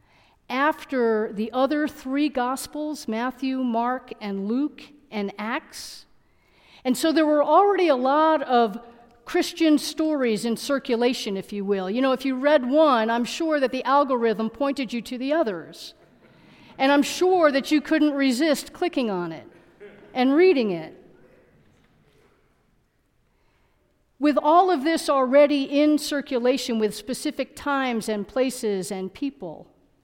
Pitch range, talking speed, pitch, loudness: 230-300 Hz, 140 wpm, 265 Hz, -23 LUFS